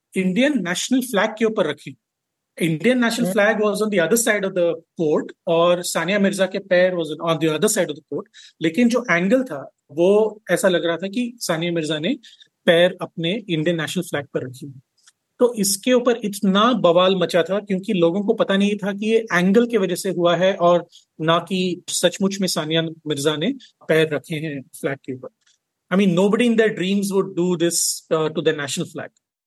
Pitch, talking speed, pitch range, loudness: 180 Hz, 195 wpm, 165-210 Hz, -20 LUFS